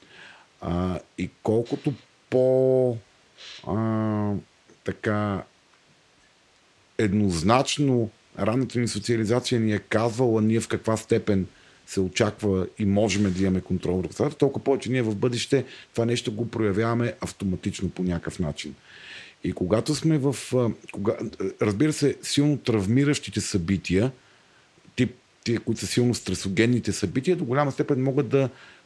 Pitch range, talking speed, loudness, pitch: 100-130 Hz, 125 wpm, -25 LUFS, 115 Hz